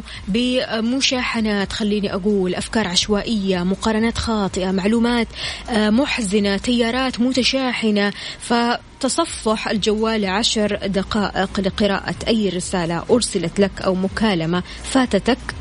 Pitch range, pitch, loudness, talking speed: 195-235 Hz, 215 Hz, -19 LUFS, 90 wpm